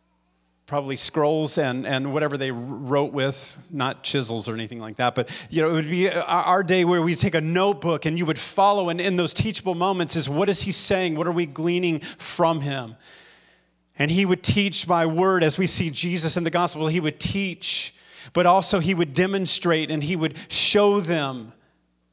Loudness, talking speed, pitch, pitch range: -21 LUFS, 200 wpm, 165 Hz, 140-180 Hz